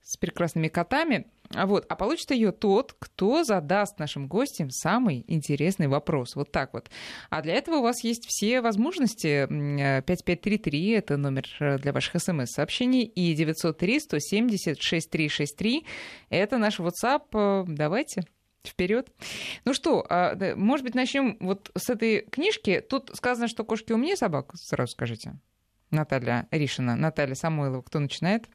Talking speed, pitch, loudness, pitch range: 135 wpm, 180 Hz, -27 LUFS, 145-230 Hz